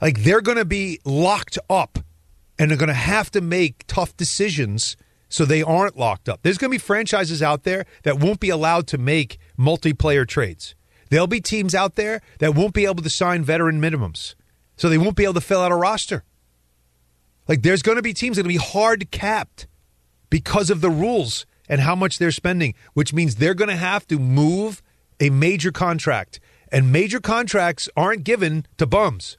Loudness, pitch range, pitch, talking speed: -20 LUFS, 135-195 Hz, 165 Hz, 200 wpm